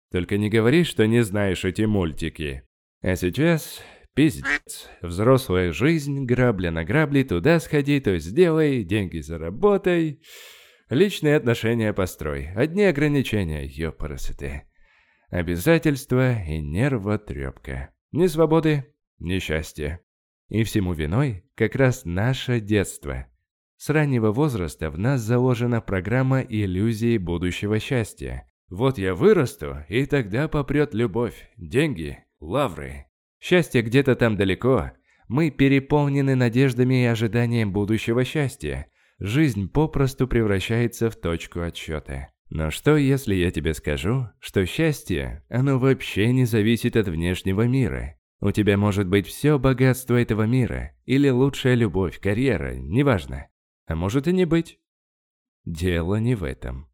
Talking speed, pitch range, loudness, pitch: 120 wpm, 85-135 Hz, -22 LUFS, 110 Hz